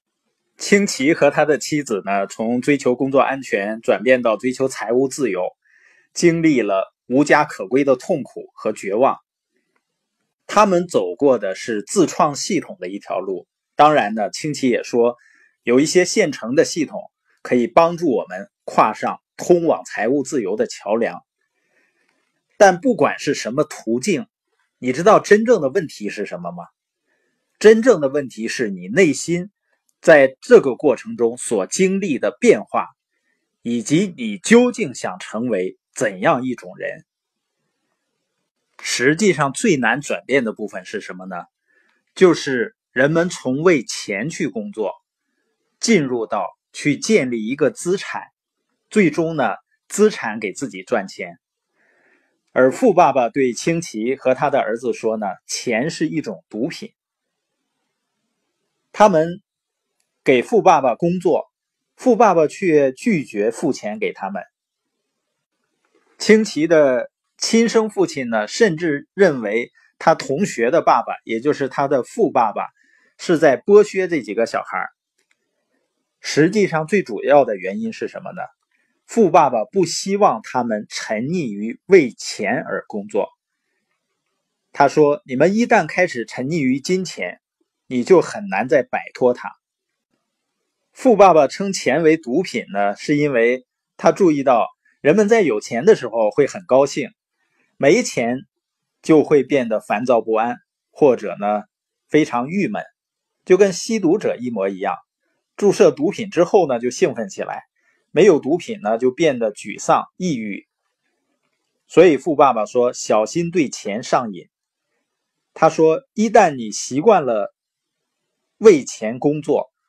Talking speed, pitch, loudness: 205 characters per minute, 170 Hz, -18 LUFS